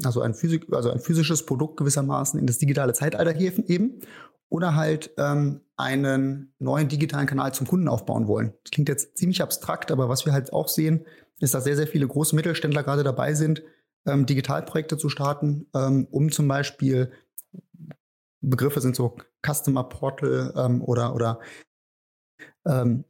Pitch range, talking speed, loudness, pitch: 130-155 Hz, 165 wpm, -24 LUFS, 145 Hz